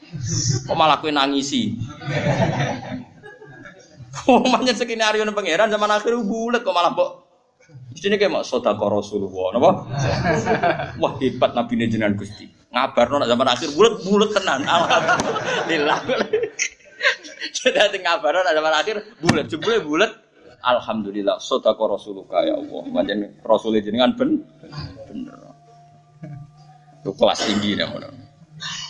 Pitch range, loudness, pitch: 135-220 Hz, -20 LUFS, 155 Hz